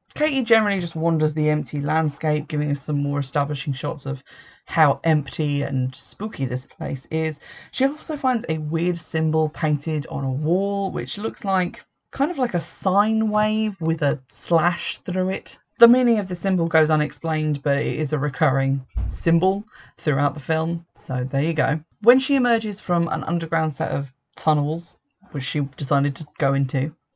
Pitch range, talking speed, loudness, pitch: 145-185 Hz, 175 wpm, -22 LUFS, 160 Hz